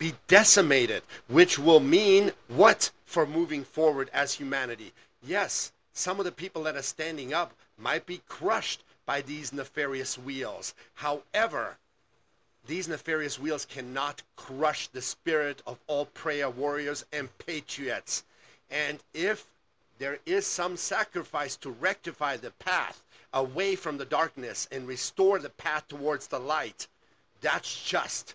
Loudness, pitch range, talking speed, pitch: -28 LUFS, 135-180 Hz, 135 wpm, 150 Hz